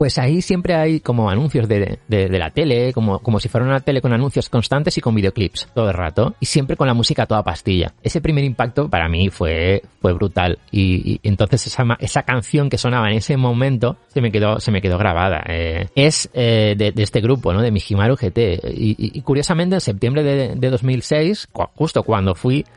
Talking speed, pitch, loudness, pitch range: 215 wpm, 120 Hz, -18 LUFS, 100-135 Hz